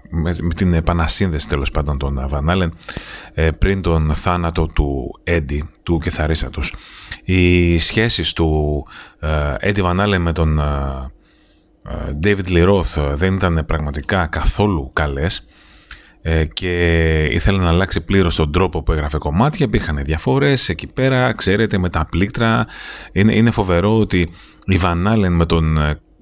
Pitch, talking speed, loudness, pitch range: 85 Hz, 120 wpm, -17 LUFS, 75-95 Hz